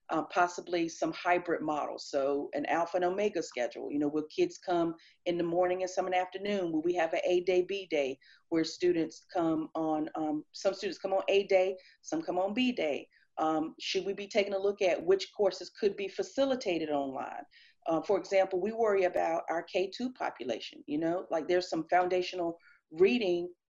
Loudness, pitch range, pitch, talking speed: -32 LUFS, 165-200 Hz, 180 Hz, 200 wpm